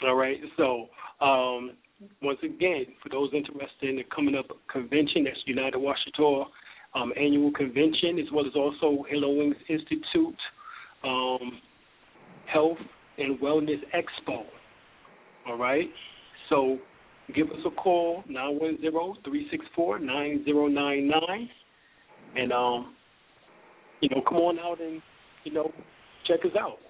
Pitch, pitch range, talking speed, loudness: 145 Hz, 135-160 Hz, 140 wpm, -28 LUFS